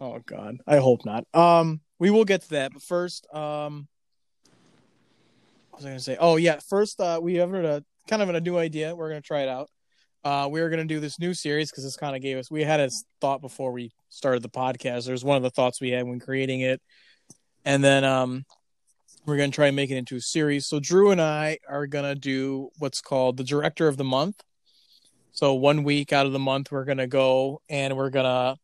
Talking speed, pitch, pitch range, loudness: 225 wpm, 140 Hz, 130-155 Hz, -24 LUFS